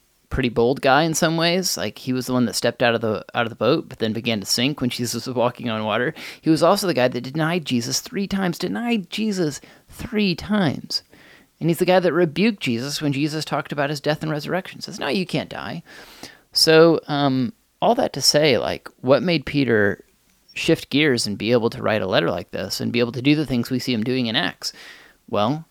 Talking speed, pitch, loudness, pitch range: 235 wpm, 140 Hz, -21 LUFS, 120-165 Hz